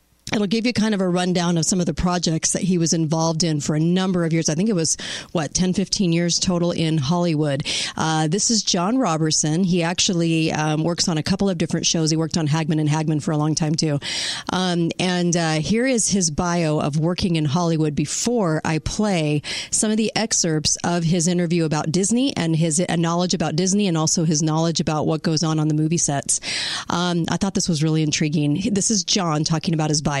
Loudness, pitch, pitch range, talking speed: -20 LUFS, 170 Hz, 160-185 Hz, 225 wpm